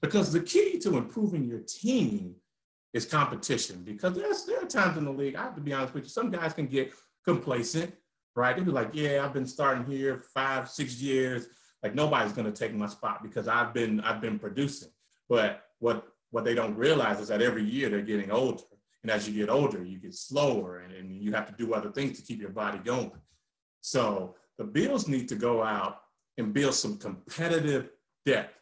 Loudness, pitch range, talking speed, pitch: -30 LUFS, 110-160 Hz, 210 wpm, 135 Hz